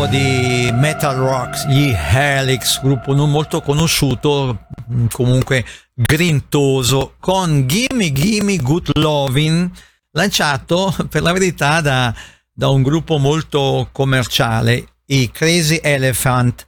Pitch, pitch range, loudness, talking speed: 140 Hz, 130-160 Hz, -15 LUFS, 105 wpm